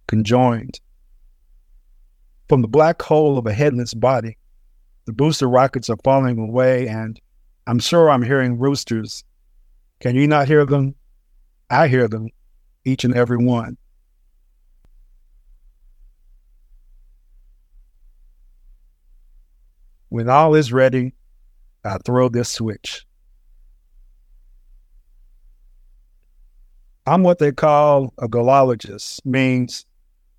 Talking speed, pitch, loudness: 95 wpm, 110 Hz, -17 LUFS